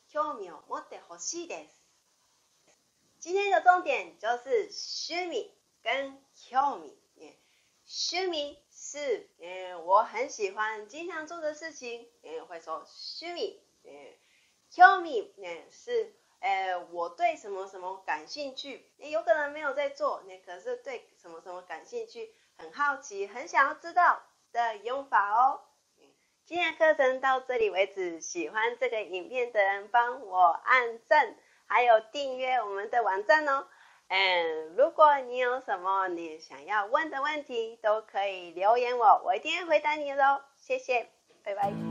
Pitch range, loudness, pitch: 210-340 Hz, -28 LUFS, 275 Hz